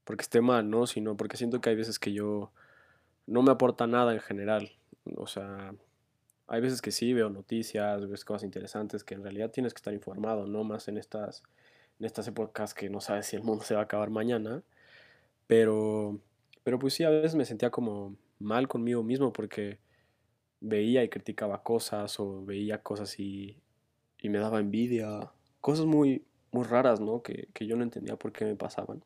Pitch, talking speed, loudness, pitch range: 110 Hz, 190 wpm, -31 LUFS, 105-120 Hz